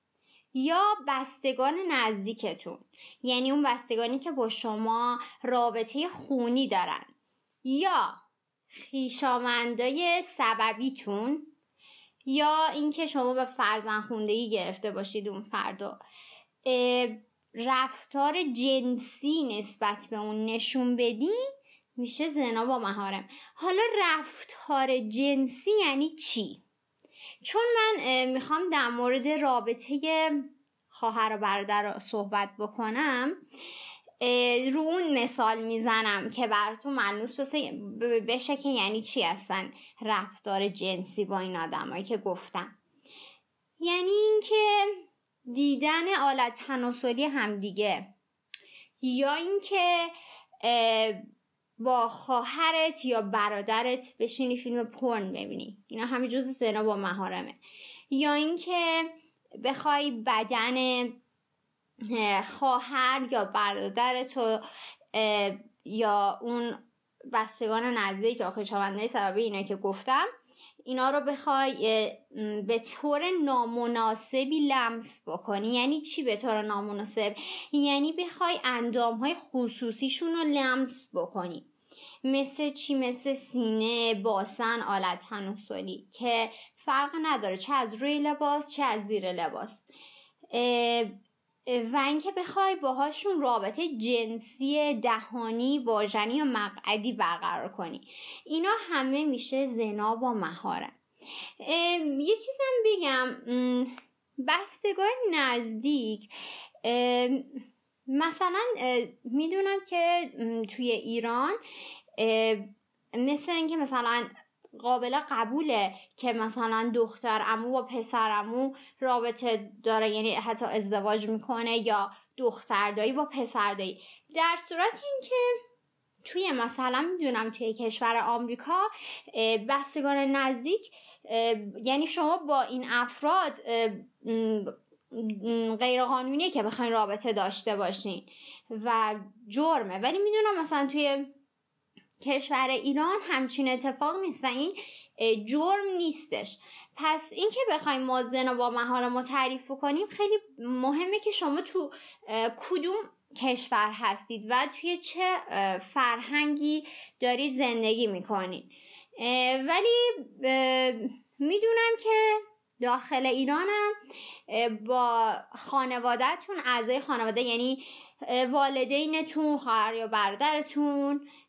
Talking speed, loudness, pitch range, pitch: 100 wpm, -29 LUFS, 225-295 Hz, 255 Hz